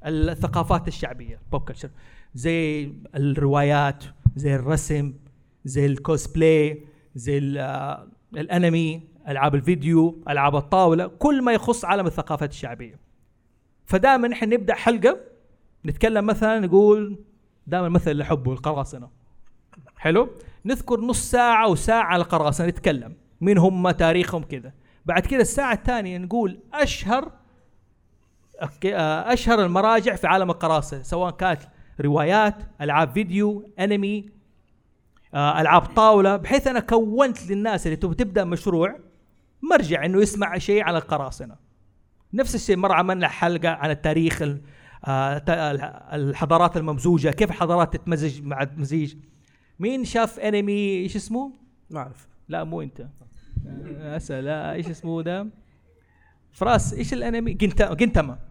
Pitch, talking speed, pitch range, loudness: 165 Hz, 110 wpm, 140-205 Hz, -22 LUFS